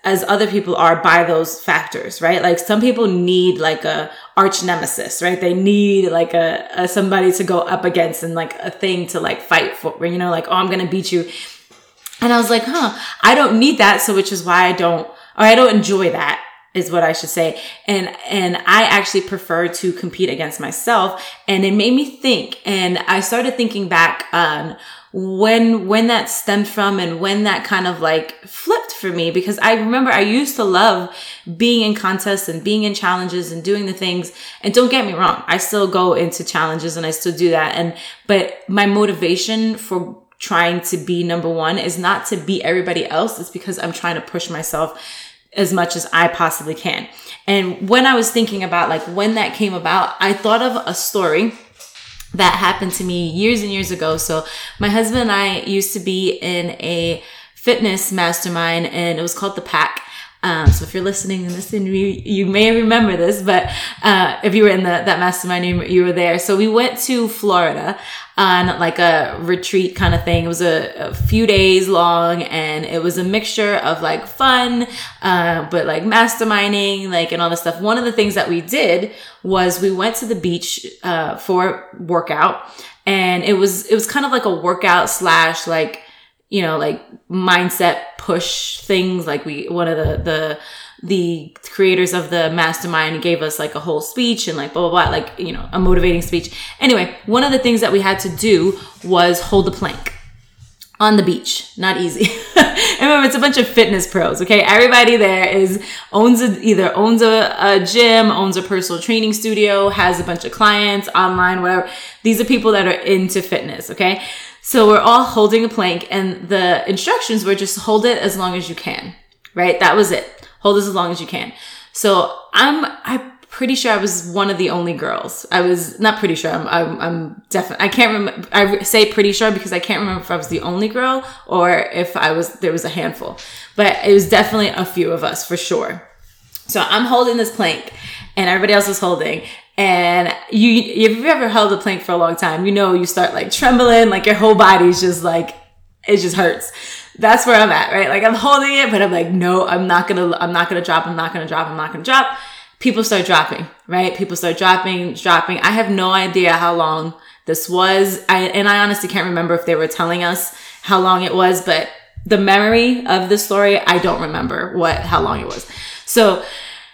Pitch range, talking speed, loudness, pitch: 175-215 Hz, 210 wpm, -15 LUFS, 190 Hz